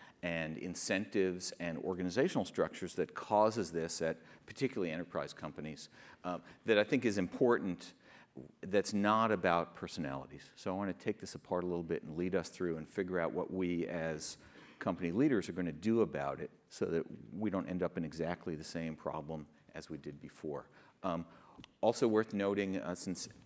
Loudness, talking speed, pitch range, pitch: -37 LUFS, 180 wpm, 80-95 Hz, 90 Hz